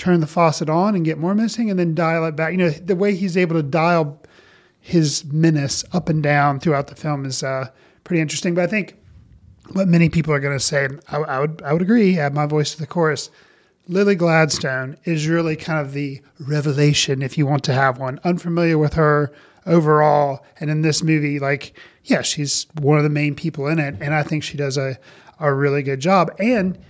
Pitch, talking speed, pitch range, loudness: 155 Hz, 220 wpm, 145-170 Hz, -19 LUFS